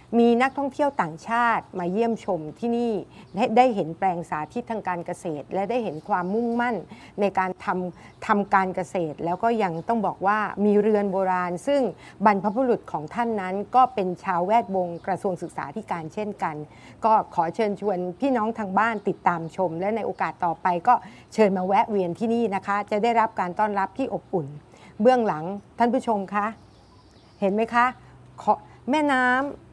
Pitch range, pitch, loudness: 180-230 Hz, 205 Hz, -24 LUFS